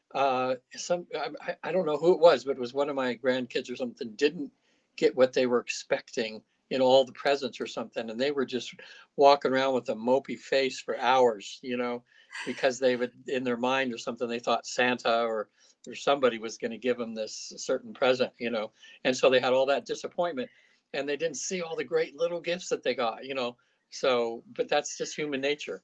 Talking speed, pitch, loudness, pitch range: 225 wpm, 135 Hz, -28 LUFS, 125-170 Hz